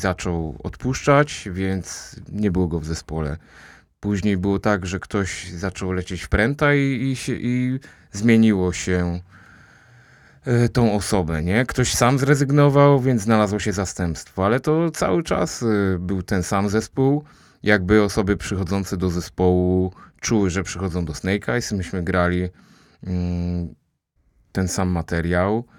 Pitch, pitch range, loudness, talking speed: 95 Hz, 90-115 Hz, -21 LUFS, 130 wpm